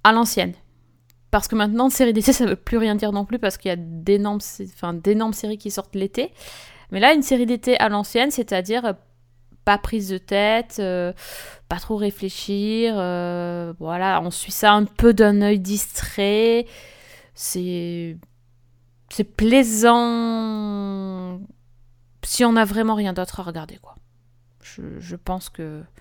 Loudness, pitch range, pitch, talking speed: -20 LUFS, 175-220 Hz, 200 Hz, 160 wpm